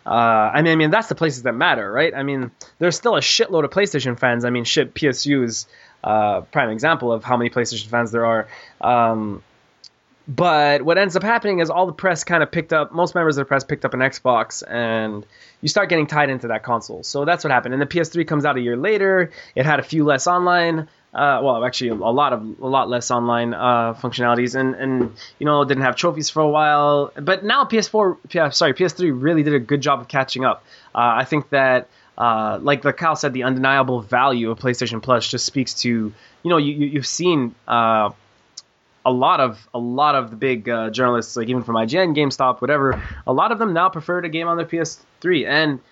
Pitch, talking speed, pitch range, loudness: 135 Hz, 225 wpm, 120-160 Hz, -19 LUFS